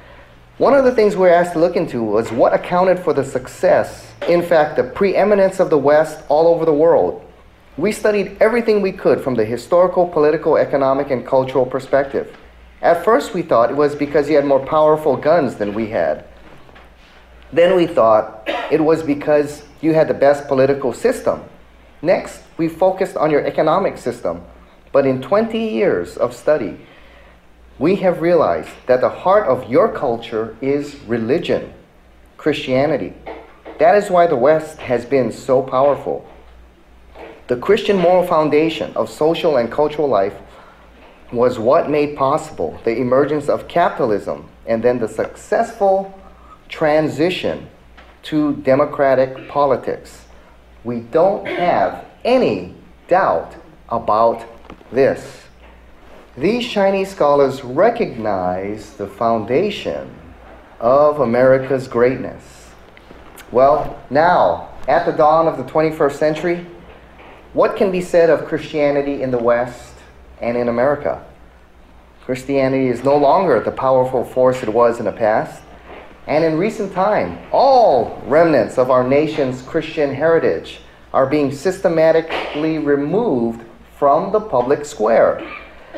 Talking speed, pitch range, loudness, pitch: 135 wpm, 115-160 Hz, -16 LUFS, 140 Hz